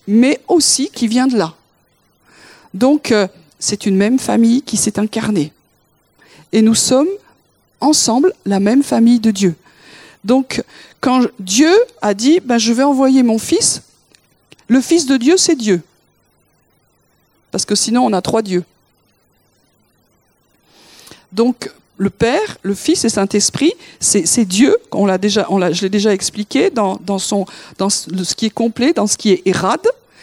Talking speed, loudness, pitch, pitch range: 160 wpm, -14 LUFS, 220 Hz, 195-265 Hz